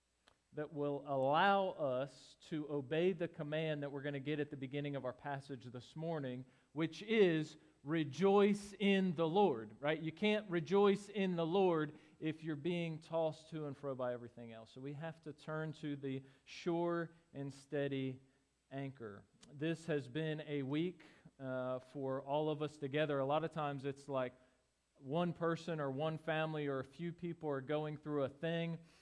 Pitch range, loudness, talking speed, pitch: 135-165 Hz, -39 LUFS, 180 wpm, 150 Hz